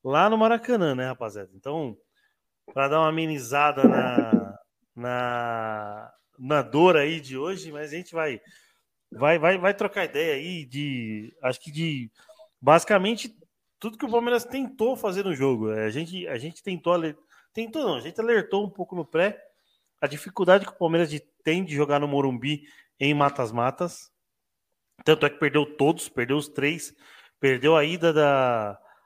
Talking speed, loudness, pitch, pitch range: 160 wpm, -25 LUFS, 155 Hz, 135-185 Hz